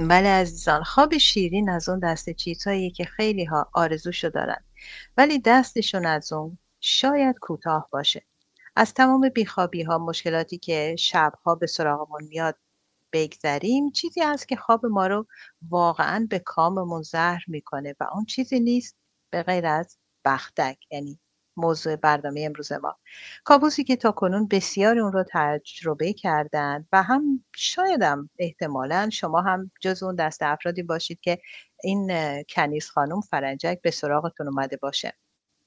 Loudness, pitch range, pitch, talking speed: -24 LUFS, 155-205 Hz, 175 Hz, 145 wpm